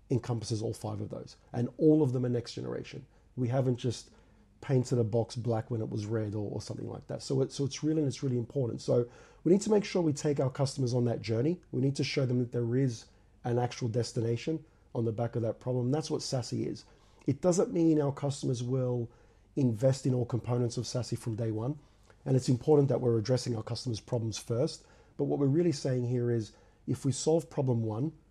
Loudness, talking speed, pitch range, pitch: -31 LUFS, 230 wpm, 115-140 Hz, 125 Hz